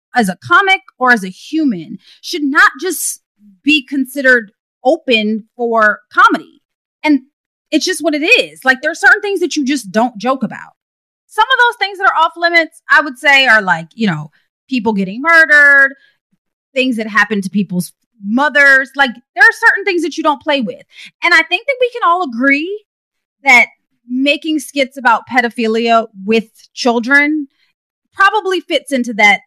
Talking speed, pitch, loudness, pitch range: 175 wpm, 280 Hz, -12 LUFS, 235-330 Hz